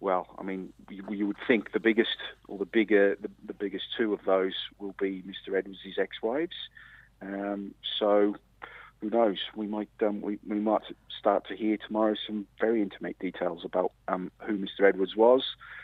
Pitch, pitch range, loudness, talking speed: 100 Hz, 95-105 Hz, -29 LUFS, 175 wpm